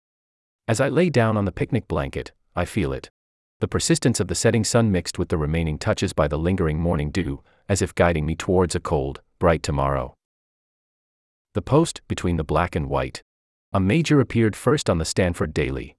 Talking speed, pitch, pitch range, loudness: 190 wpm, 90 Hz, 80-110 Hz, -22 LUFS